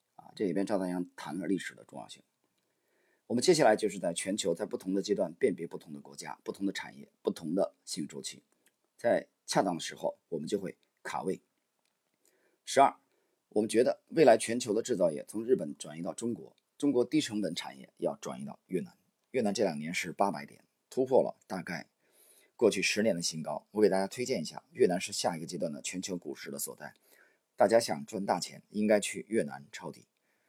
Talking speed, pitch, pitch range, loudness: 300 characters per minute, 105 Hz, 90-115 Hz, -32 LUFS